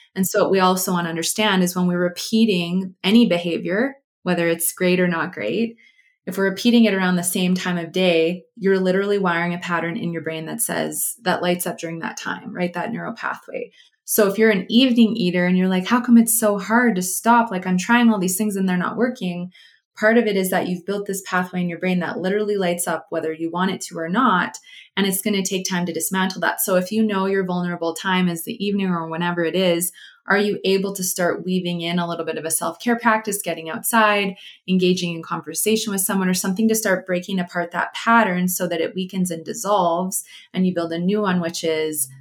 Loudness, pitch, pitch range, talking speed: -20 LUFS, 185 Hz, 175-210 Hz, 235 wpm